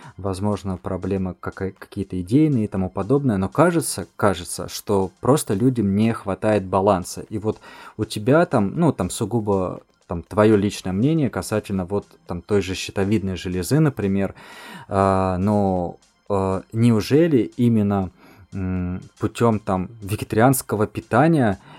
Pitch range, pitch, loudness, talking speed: 95-110 Hz, 100 Hz, -21 LUFS, 120 wpm